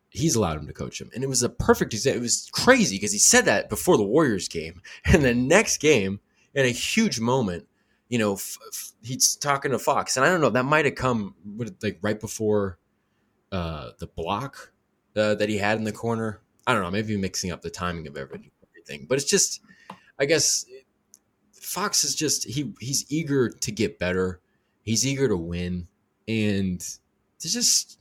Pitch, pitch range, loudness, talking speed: 110 Hz, 100-135 Hz, -23 LUFS, 195 wpm